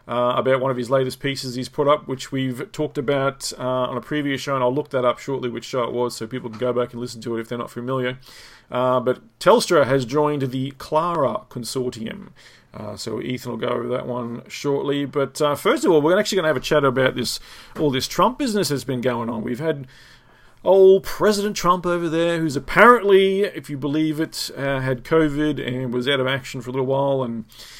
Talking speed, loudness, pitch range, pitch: 235 wpm, -21 LUFS, 125-150 Hz, 130 Hz